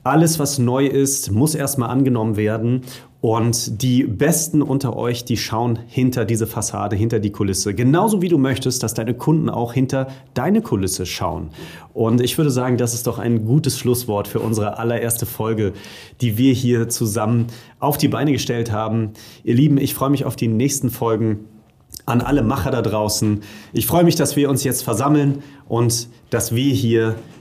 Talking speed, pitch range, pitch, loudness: 180 wpm, 115-135 Hz, 120 Hz, -19 LUFS